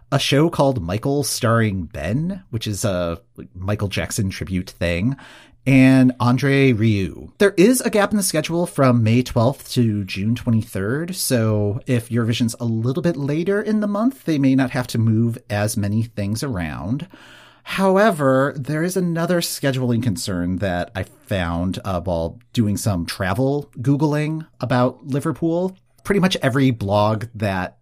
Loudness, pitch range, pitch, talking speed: -20 LUFS, 105-145 Hz, 125 Hz, 155 wpm